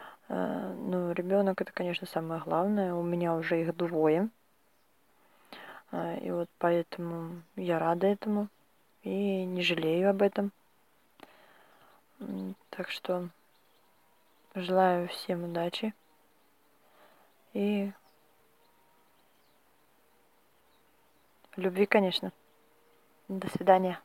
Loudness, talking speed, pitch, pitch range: -31 LUFS, 80 wpm, 180 Hz, 170-195 Hz